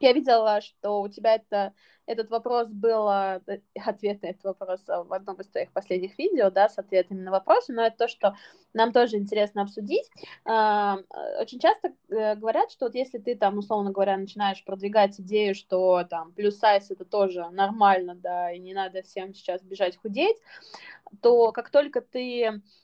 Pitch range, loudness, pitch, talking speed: 195-230 Hz, -26 LUFS, 205 Hz, 170 wpm